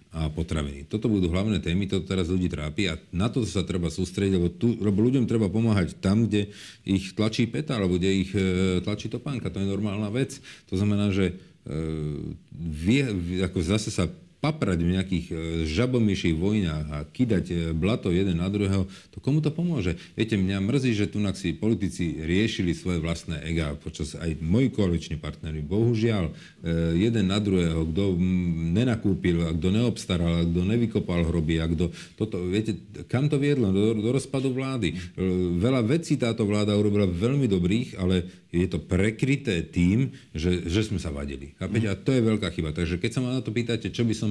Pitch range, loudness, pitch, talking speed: 85-110 Hz, -26 LUFS, 95 Hz, 175 wpm